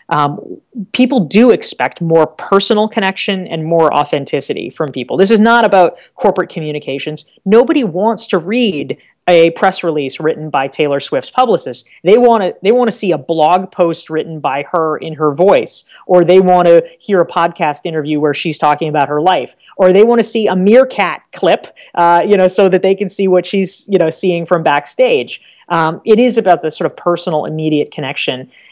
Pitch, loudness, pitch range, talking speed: 180 Hz, -12 LUFS, 160-205 Hz, 190 wpm